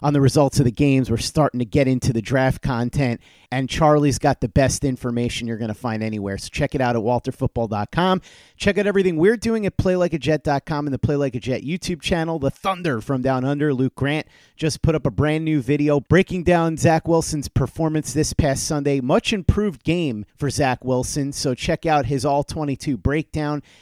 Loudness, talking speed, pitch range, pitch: -21 LUFS, 205 wpm, 130-155 Hz, 140 Hz